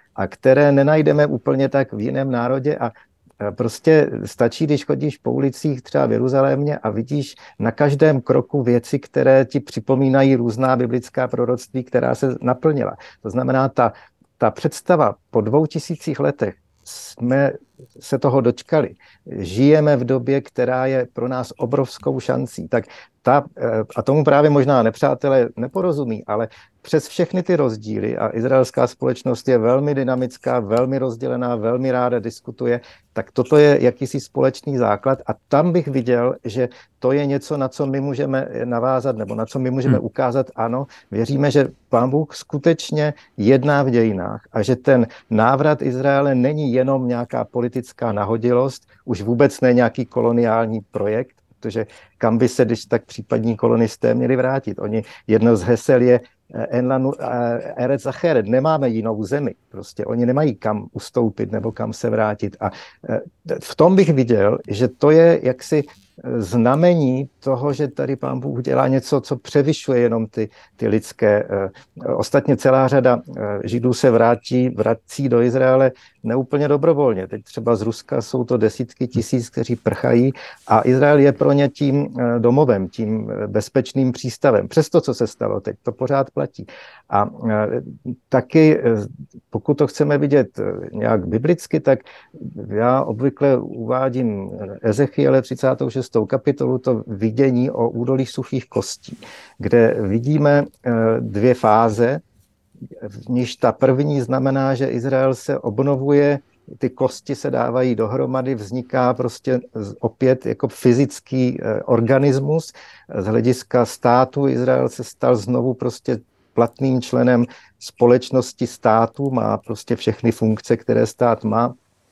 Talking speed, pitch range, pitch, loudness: 140 wpm, 115-135 Hz, 125 Hz, -19 LUFS